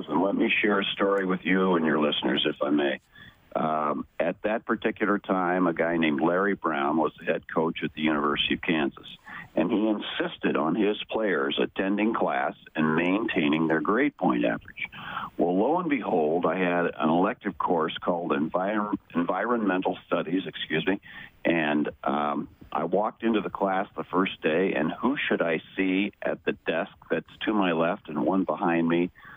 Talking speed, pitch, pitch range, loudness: 180 wpm, 90 Hz, 80-95 Hz, -26 LUFS